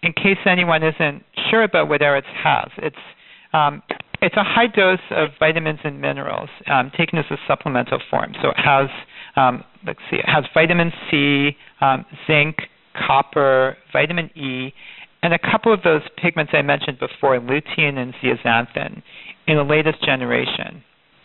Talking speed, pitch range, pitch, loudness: 160 wpm, 140-170 Hz, 155 Hz, -18 LUFS